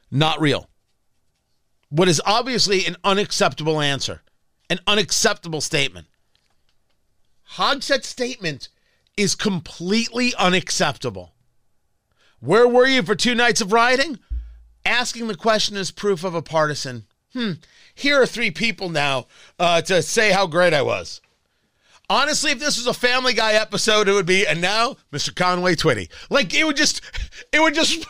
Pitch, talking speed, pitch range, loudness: 195 Hz, 145 wpm, 160-235 Hz, -19 LUFS